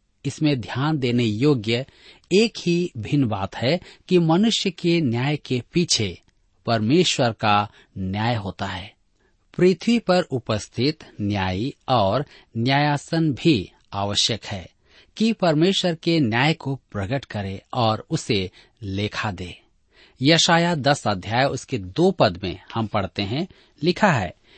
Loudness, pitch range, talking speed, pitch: -22 LUFS, 105-165 Hz, 125 wpm, 130 Hz